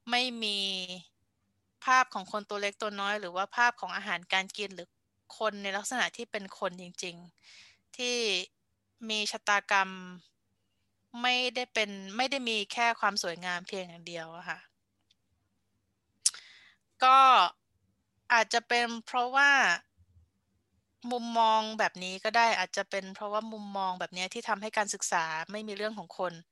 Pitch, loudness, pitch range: 195 Hz, -29 LUFS, 170-220 Hz